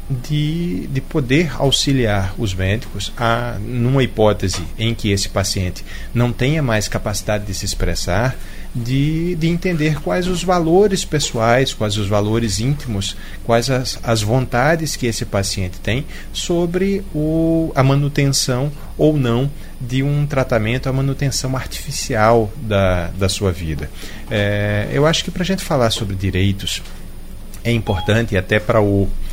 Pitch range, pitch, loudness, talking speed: 100-140 Hz, 115 Hz, -18 LUFS, 145 wpm